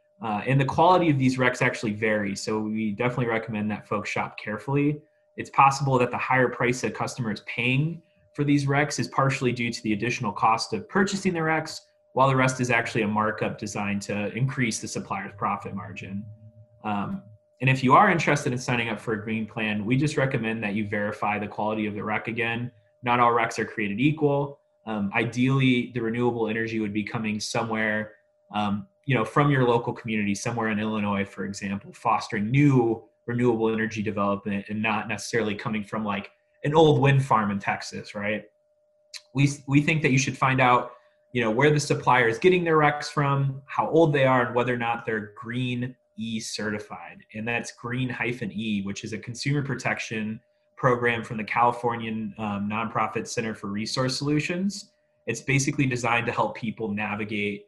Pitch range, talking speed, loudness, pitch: 110-135 Hz, 190 wpm, -25 LUFS, 120 Hz